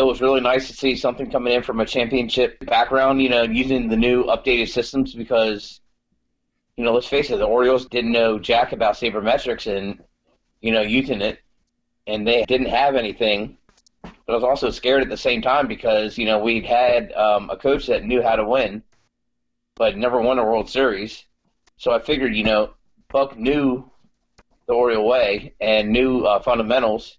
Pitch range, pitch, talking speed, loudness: 110-130 Hz, 120 Hz, 190 wpm, -20 LUFS